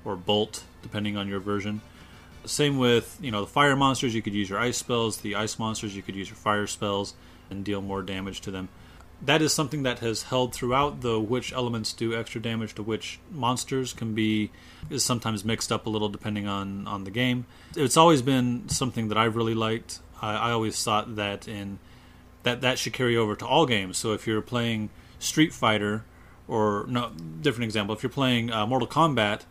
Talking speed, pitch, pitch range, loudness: 205 wpm, 110 Hz, 100-120 Hz, -27 LUFS